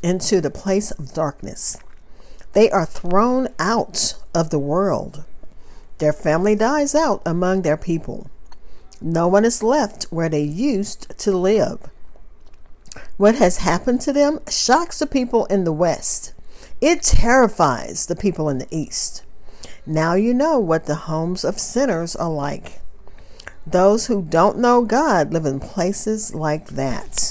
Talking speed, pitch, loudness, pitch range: 145 wpm, 180 Hz, -19 LUFS, 155-220 Hz